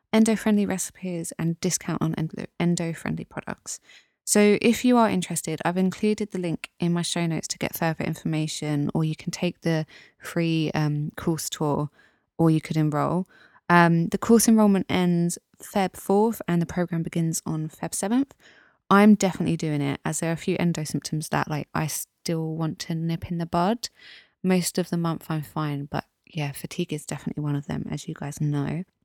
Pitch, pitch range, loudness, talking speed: 170 Hz, 155-185 Hz, -25 LUFS, 185 wpm